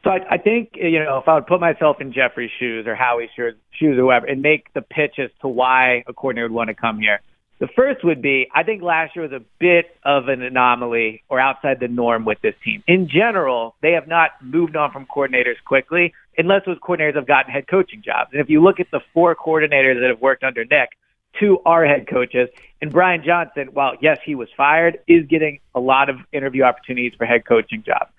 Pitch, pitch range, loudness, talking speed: 140 Hz, 125-165 Hz, -17 LUFS, 230 wpm